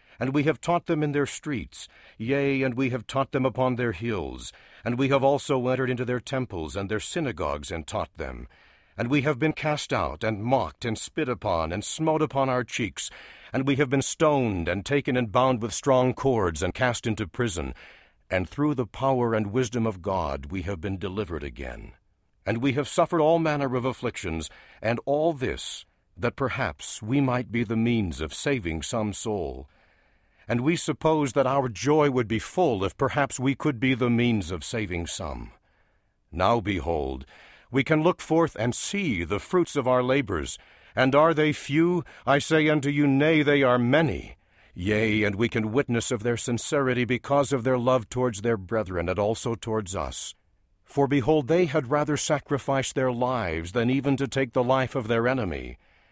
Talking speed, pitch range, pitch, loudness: 190 wpm, 105-140 Hz, 125 Hz, -26 LUFS